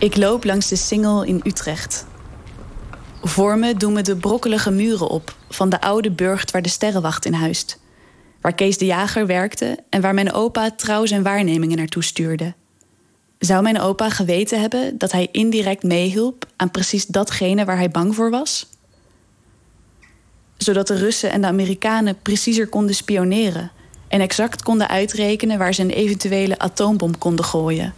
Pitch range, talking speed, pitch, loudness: 175-210 Hz, 160 wpm, 195 Hz, -19 LUFS